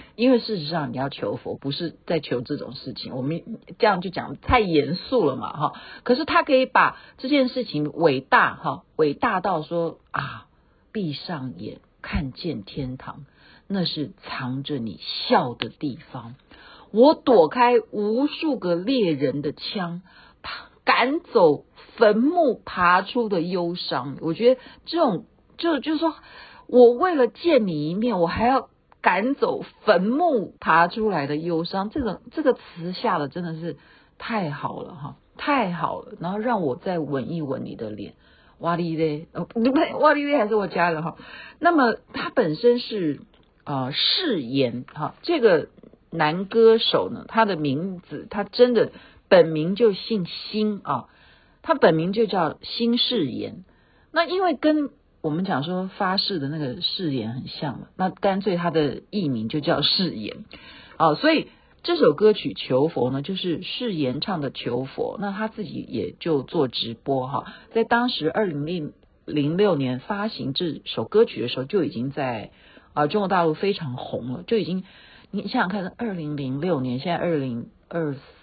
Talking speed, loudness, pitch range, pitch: 225 characters per minute, -23 LUFS, 150-235 Hz, 185 Hz